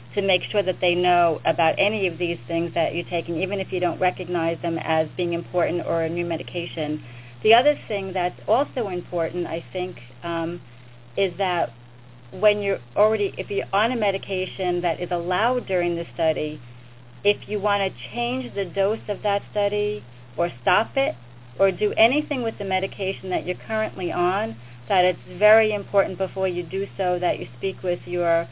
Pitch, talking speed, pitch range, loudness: 180 Hz, 185 wpm, 165-200 Hz, -23 LUFS